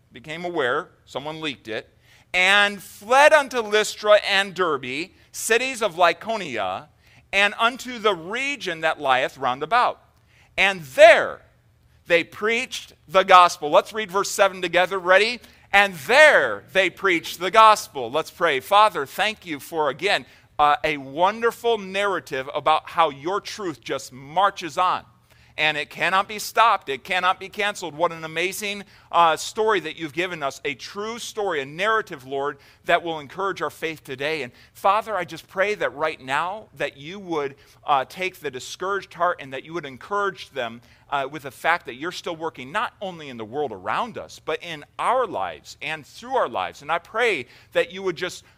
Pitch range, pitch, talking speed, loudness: 155-205 Hz, 180 Hz, 170 wpm, -22 LUFS